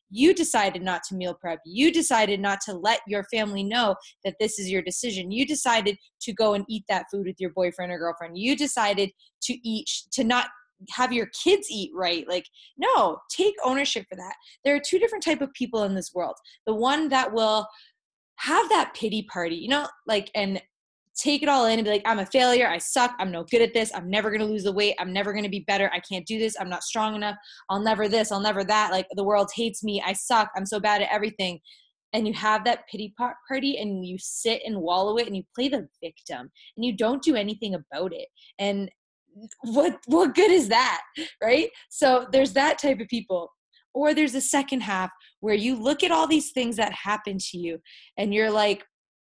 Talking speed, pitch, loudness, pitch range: 225 wpm, 215 Hz, -25 LUFS, 195-255 Hz